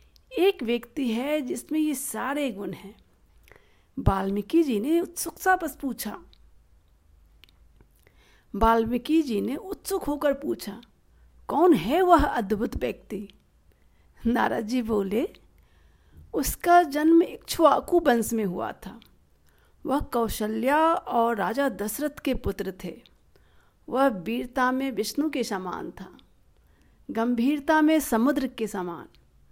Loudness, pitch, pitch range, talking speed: -25 LUFS, 245 Hz, 205-300 Hz, 115 wpm